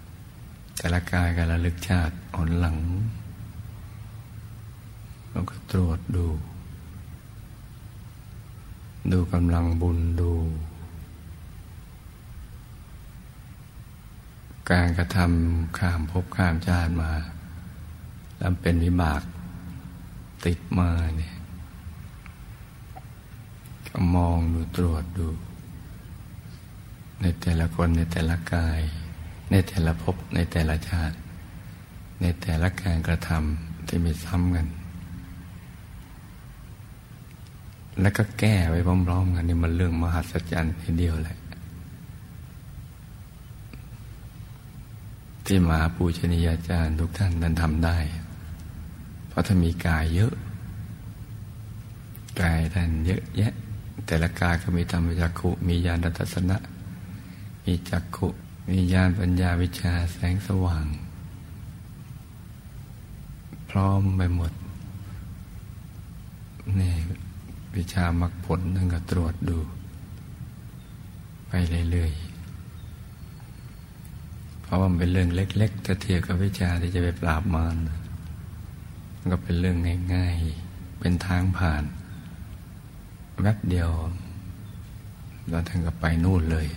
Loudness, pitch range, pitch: -26 LUFS, 85-95 Hz, 90 Hz